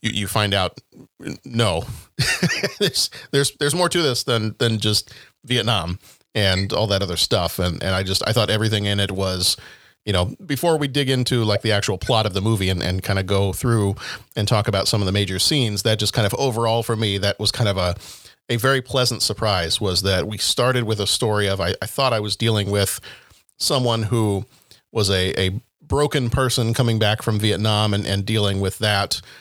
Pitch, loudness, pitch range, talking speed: 105 Hz, -20 LUFS, 100-120 Hz, 210 wpm